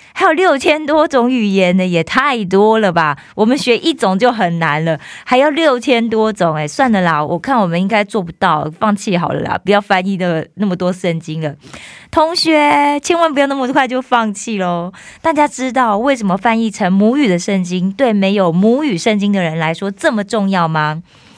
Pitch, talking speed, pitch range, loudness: 205 Hz, 290 characters per minute, 180-255 Hz, -14 LUFS